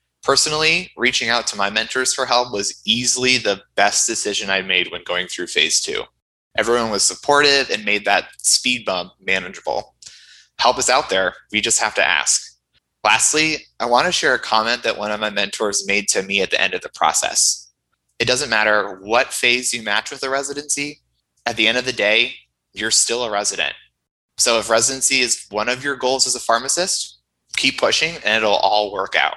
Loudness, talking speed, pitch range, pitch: -17 LUFS, 200 wpm, 105-135 Hz, 120 Hz